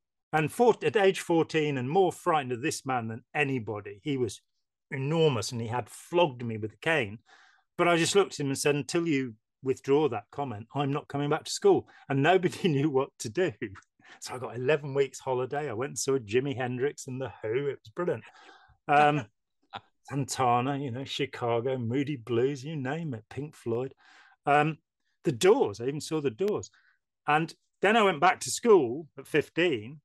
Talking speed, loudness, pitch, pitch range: 190 wpm, -28 LUFS, 140 Hz, 130-160 Hz